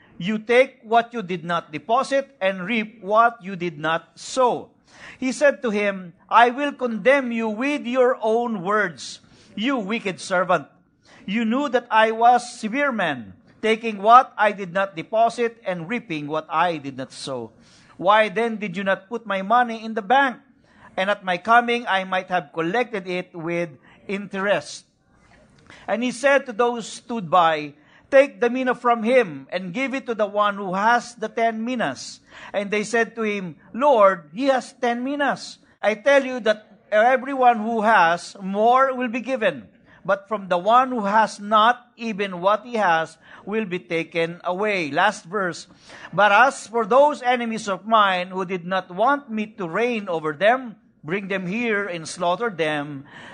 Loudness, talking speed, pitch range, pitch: -21 LUFS, 175 wpm, 185-240 Hz, 220 Hz